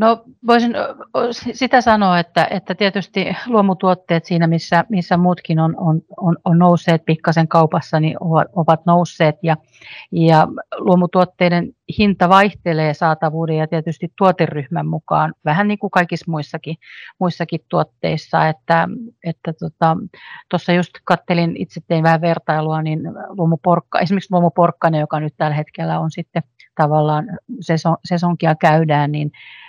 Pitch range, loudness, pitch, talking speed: 160-185 Hz, -17 LUFS, 170 Hz, 130 wpm